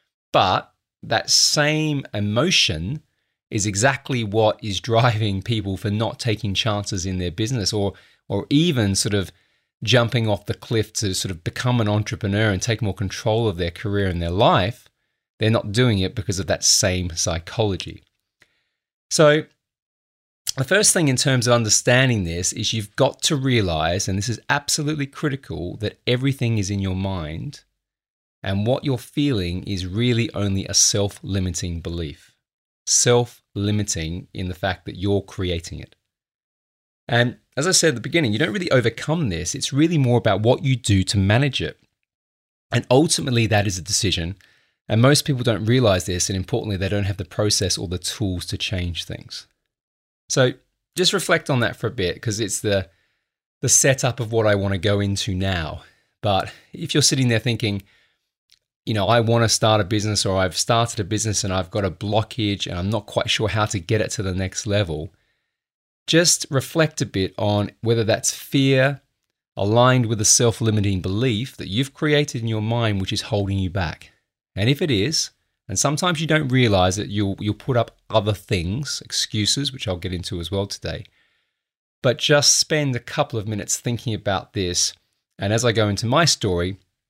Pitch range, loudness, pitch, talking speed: 95-125 Hz, -20 LUFS, 110 Hz, 185 wpm